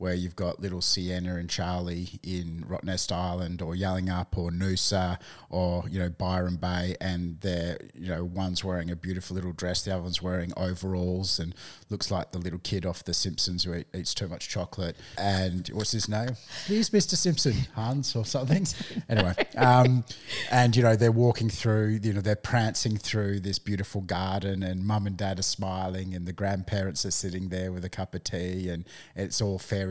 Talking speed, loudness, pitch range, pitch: 195 wpm, -28 LUFS, 90-105 Hz, 95 Hz